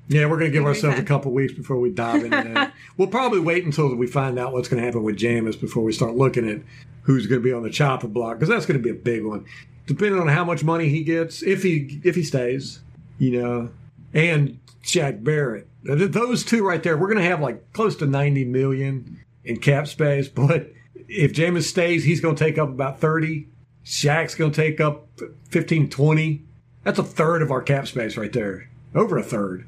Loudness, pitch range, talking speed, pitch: -22 LUFS, 125-160 Hz, 225 wpm, 140 Hz